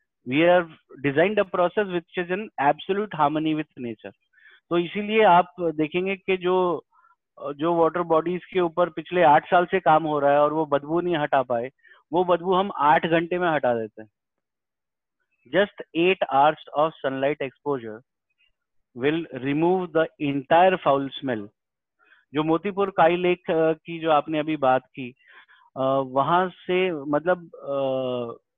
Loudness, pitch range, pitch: -23 LUFS, 140-180 Hz, 160 Hz